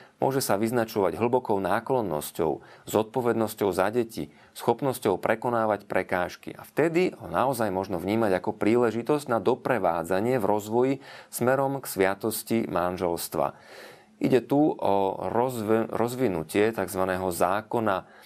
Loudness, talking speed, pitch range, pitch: -26 LUFS, 110 wpm, 95-120 Hz, 110 Hz